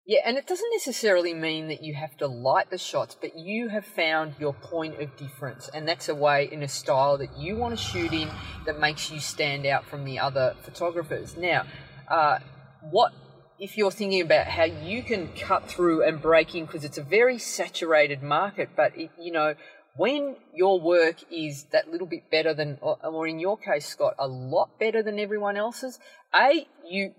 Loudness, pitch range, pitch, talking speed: -26 LUFS, 150-205 Hz, 160 Hz, 200 wpm